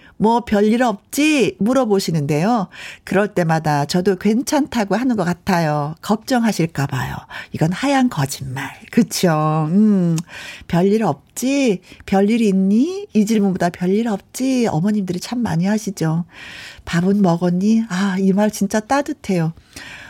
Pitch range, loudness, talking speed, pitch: 170-225 Hz, -18 LUFS, 265 characters per minute, 195 Hz